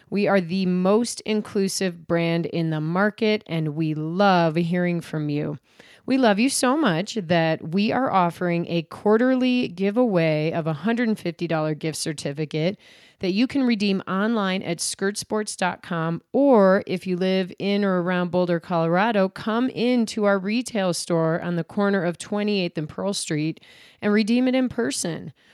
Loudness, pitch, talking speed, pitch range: -23 LUFS, 190 Hz, 155 wpm, 170-215 Hz